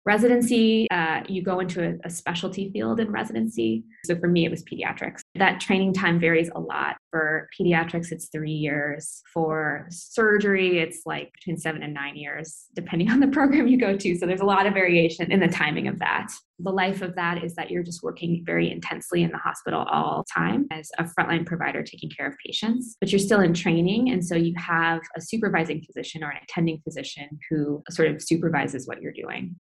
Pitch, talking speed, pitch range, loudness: 170 Hz, 210 wpm, 160-190 Hz, -24 LUFS